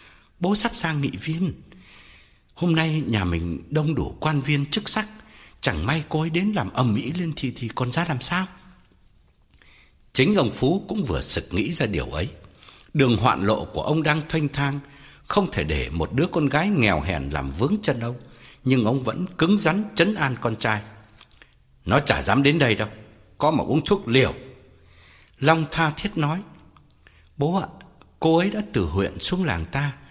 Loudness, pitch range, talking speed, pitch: -23 LUFS, 100-165 Hz, 190 wpm, 140 Hz